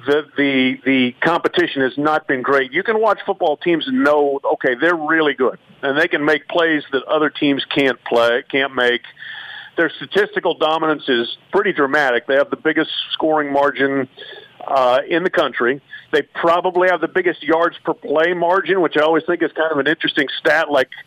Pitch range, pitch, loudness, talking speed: 140-170 Hz, 155 Hz, -17 LUFS, 190 wpm